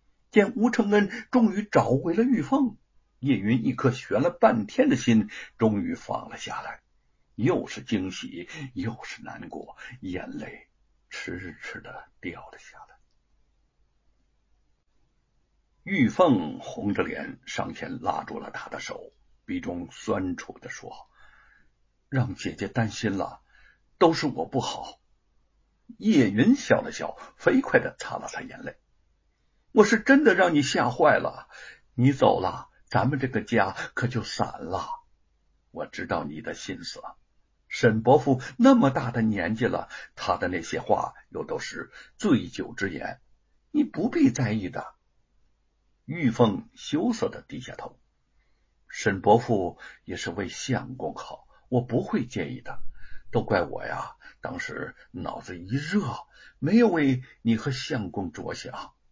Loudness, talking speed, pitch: -26 LUFS, 190 characters per minute, 140 Hz